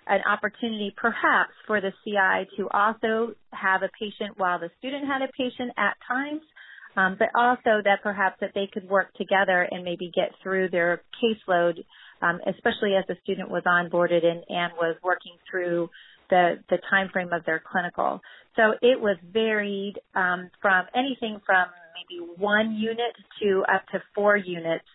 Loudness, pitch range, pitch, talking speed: -25 LUFS, 180-220 Hz, 195 Hz, 165 wpm